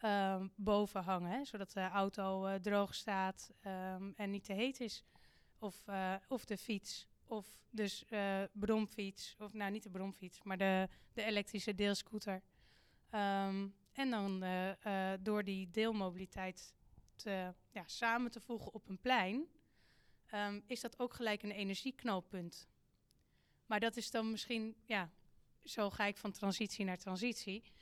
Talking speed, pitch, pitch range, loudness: 155 wpm, 205 Hz, 190-220 Hz, -41 LUFS